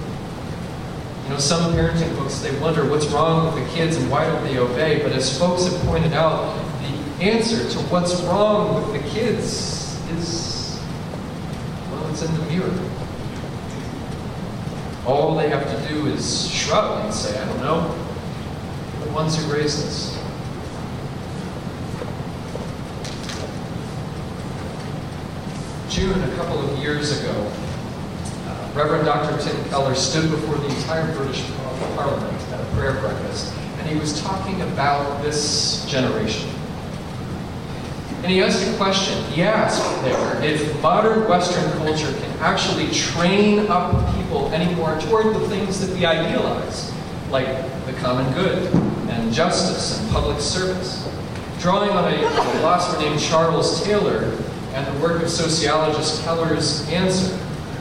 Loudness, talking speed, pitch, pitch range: -21 LUFS, 130 wpm, 155 Hz, 150-175 Hz